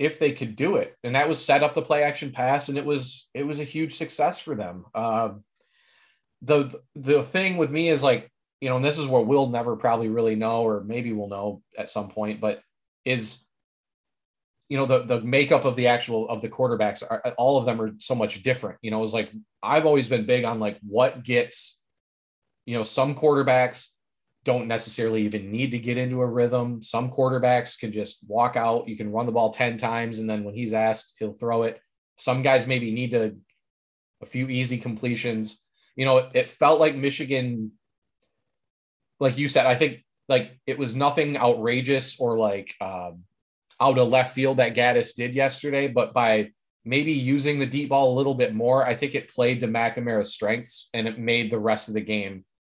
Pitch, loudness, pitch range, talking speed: 125 Hz, -24 LUFS, 110-135 Hz, 205 wpm